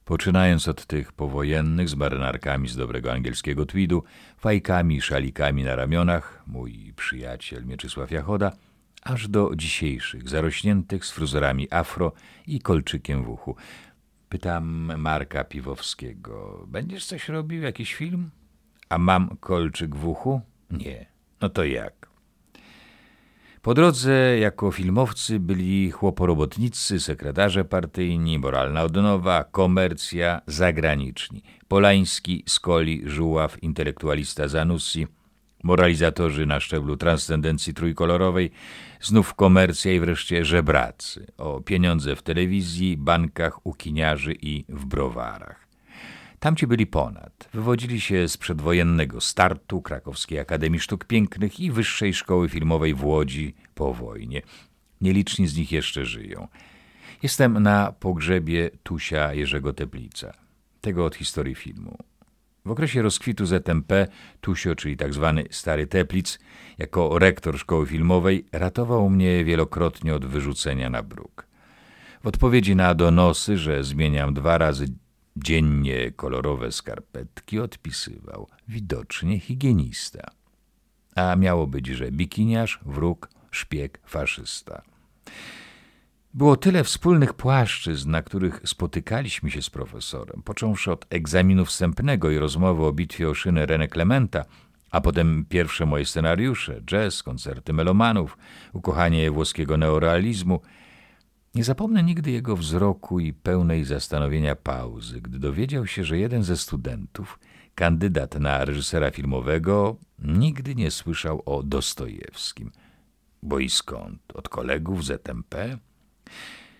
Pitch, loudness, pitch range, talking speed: 85 Hz, -24 LUFS, 75-95 Hz, 115 wpm